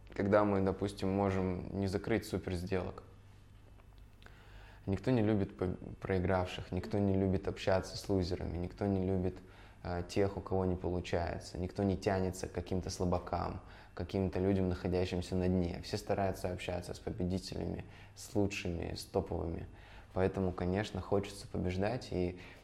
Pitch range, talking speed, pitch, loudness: 90-100 Hz, 140 wpm, 95 Hz, -36 LUFS